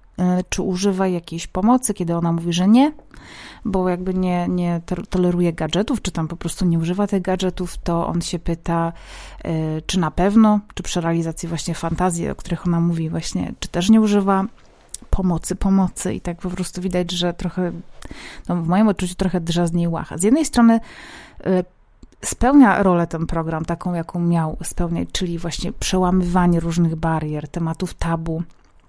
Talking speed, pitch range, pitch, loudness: 165 wpm, 170-185 Hz, 175 Hz, -20 LUFS